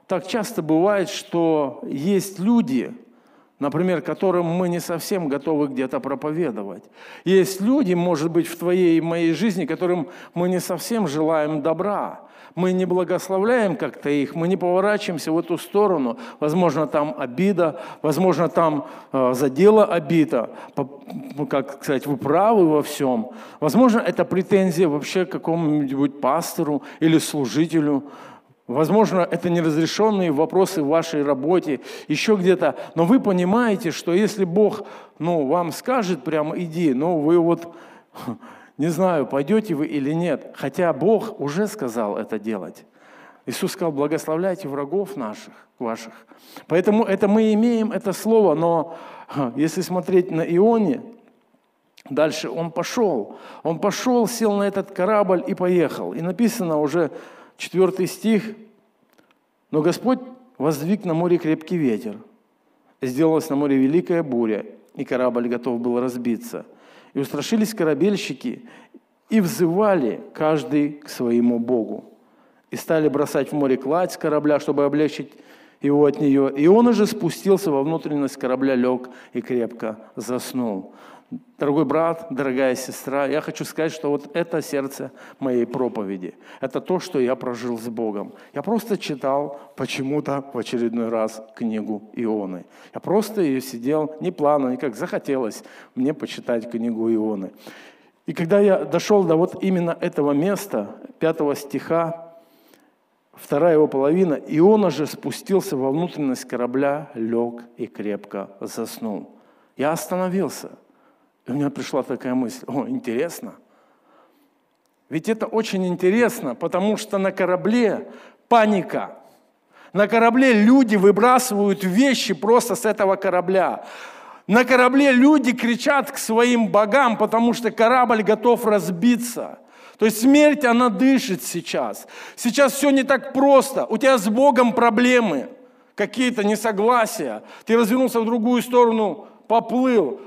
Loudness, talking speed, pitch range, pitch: -21 LUFS, 135 wpm, 145-215 Hz, 175 Hz